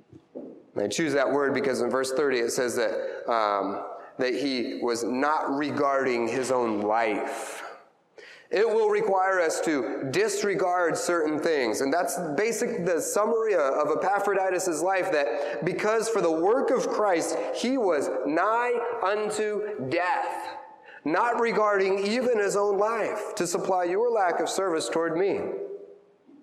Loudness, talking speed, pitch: -26 LUFS, 140 wpm, 205 Hz